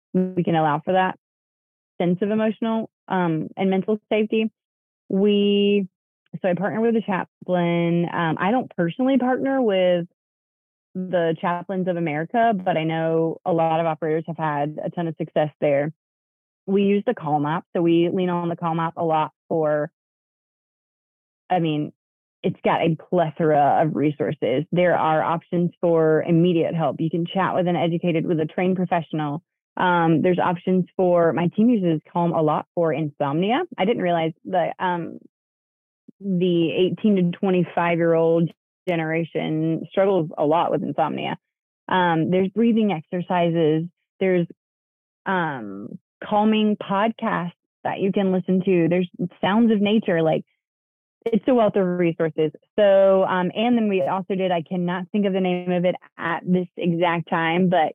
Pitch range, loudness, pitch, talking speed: 165-195 Hz, -22 LUFS, 175 Hz, 160 wpm